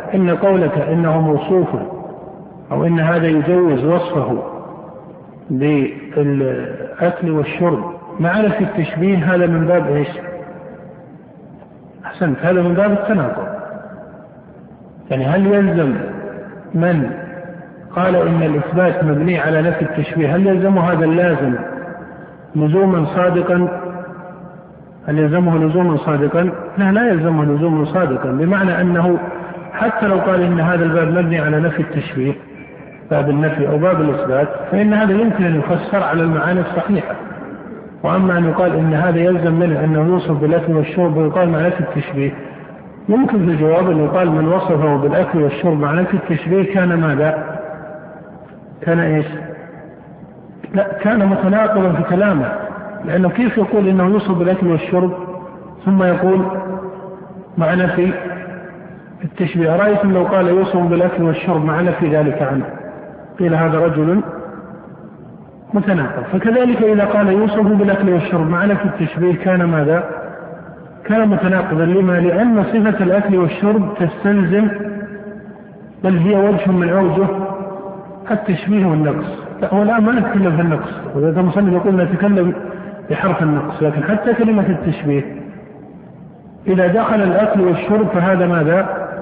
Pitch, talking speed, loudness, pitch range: 180 Hz, 125 wpm, -15 LUFS, 165-195 Hz